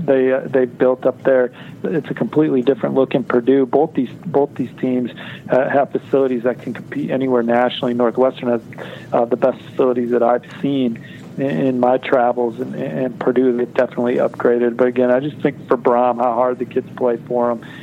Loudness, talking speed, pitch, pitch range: -18 LUFS, 195 wpm, 125 Hz, 120-135 Hz